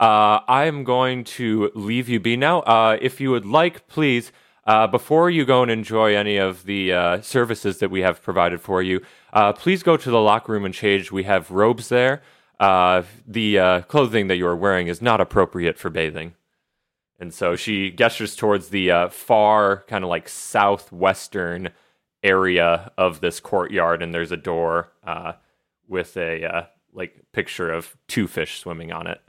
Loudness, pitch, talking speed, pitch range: -20 LUFS, 100 Hz, 185 wpm, 90-115 Hz